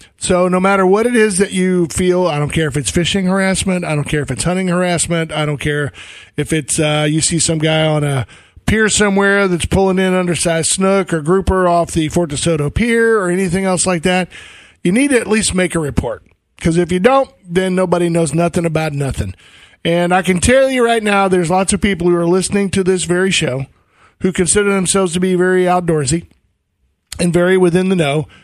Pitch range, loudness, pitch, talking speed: 160-190 Hz, -14 LUFS, 180 Hz, 215 wpm